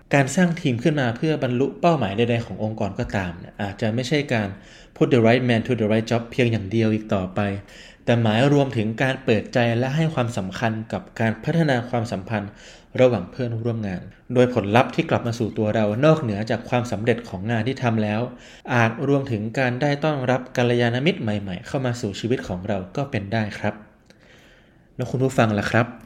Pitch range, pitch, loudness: 110-130 Hz, 115 Hz, -22 LUFS